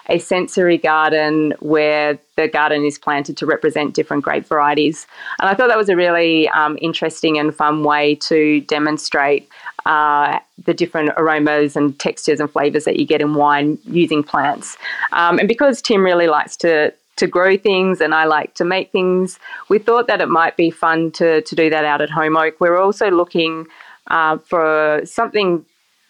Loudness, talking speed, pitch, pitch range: -16 LUFS, 180 wpm, 155 Hz, 150-175 Hz